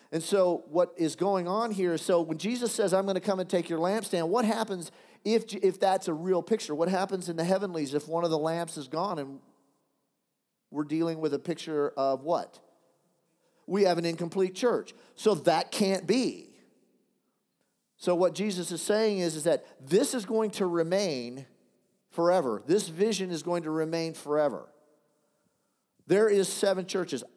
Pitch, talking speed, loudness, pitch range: 180 Hz, 180 wpm, -29 LUFS, 165-200 Hz